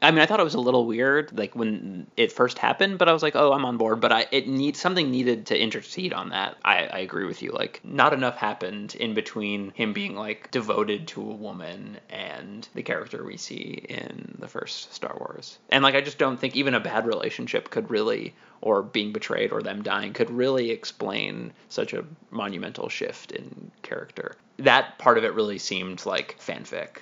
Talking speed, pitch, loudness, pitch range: 210 wpm, 130 Hz, -25 LUFS, 115-150 Hz